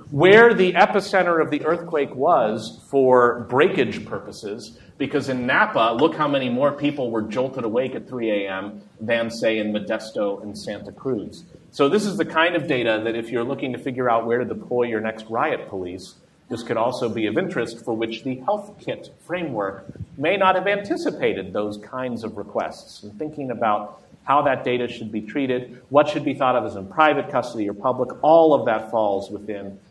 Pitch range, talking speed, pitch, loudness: 110-150 Hz, 195 wpm, 125 Hz, -21 LUFS